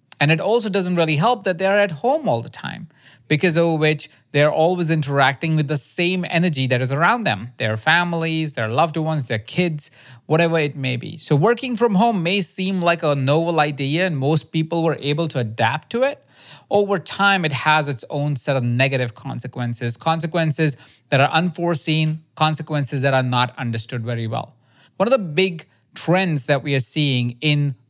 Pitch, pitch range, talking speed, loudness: 155 Hz, 135-170 Hz, 190 wpm, -19 LUFS